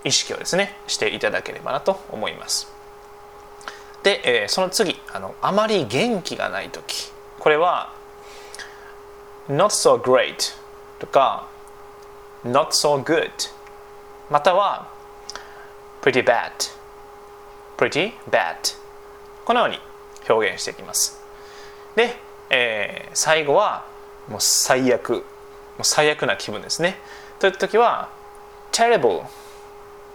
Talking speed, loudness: 260 characters per minute, -20 LUFS